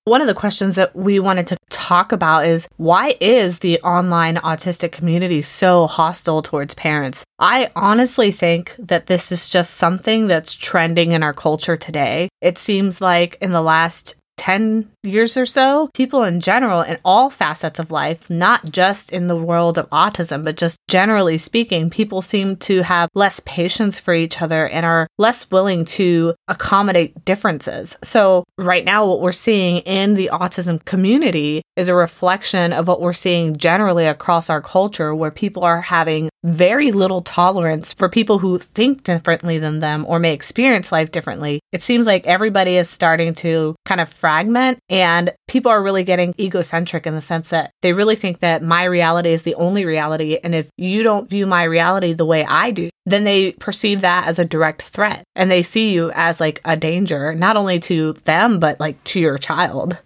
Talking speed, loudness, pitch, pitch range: 185 wpm, -16 LUFS, 175 Hz, 165-195 Hz